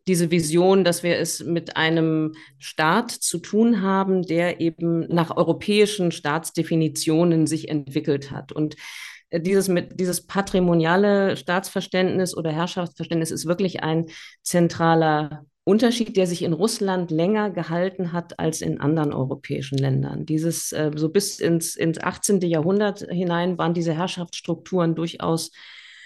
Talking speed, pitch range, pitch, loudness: 130 wpm, 160-185 Hz, 170 Hz, -22 LUFS